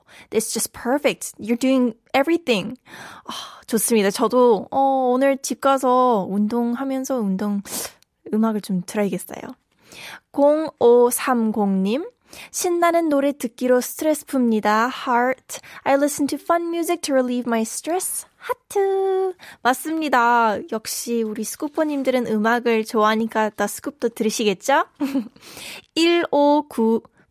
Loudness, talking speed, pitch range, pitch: -20 LUFS, 335 characters per minute, 225-285 Hz, 250 Hz